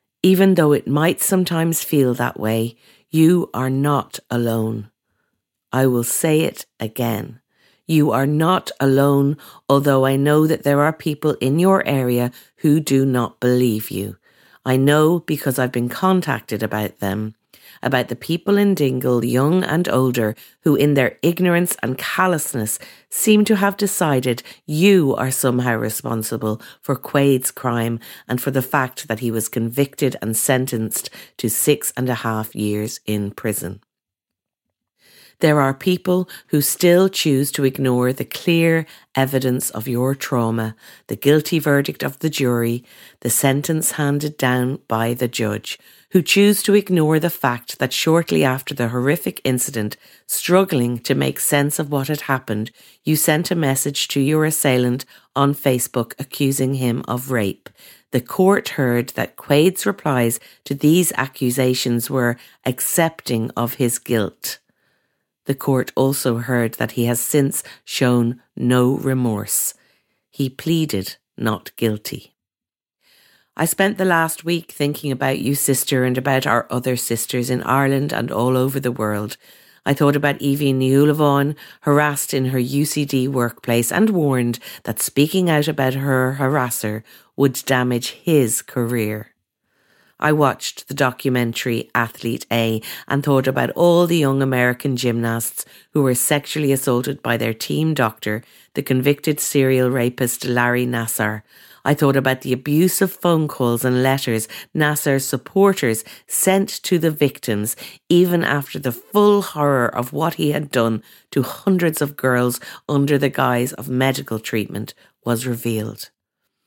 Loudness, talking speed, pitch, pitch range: -19 LUFS, 145 wpm, 135 Hz, 120-150 Hz